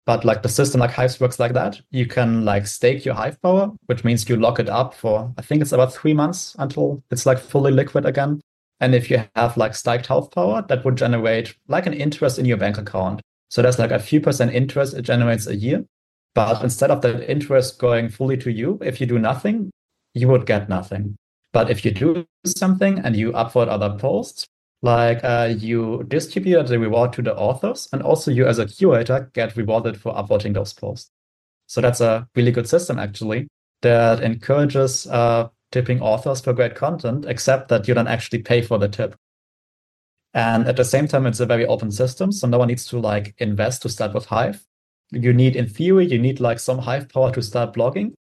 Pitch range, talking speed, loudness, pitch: 115-135 Hz, 210 wpm, -20 LUFS, 120 Hz